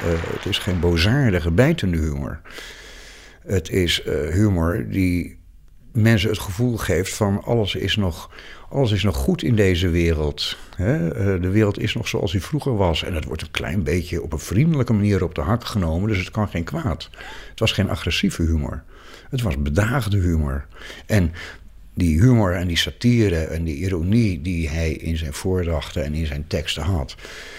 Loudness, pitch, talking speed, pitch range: -21 LUFS, 95 Hz, 180 wpm, 85-110 Hz